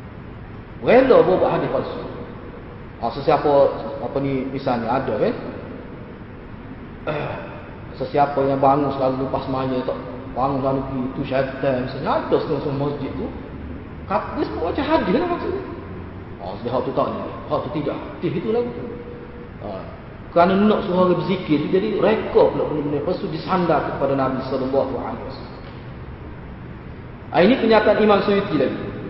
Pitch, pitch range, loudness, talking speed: 135 Hz, 130-155 Hz, -20 LUFS, 140 wpm